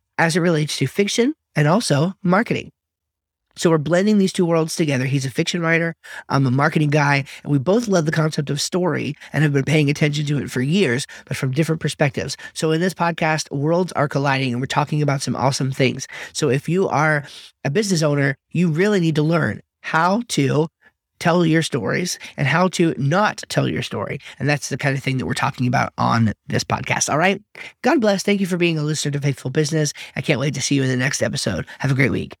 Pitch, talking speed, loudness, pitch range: 150 Hz, 225 wpm, -20 LUFS, 140-170 Hz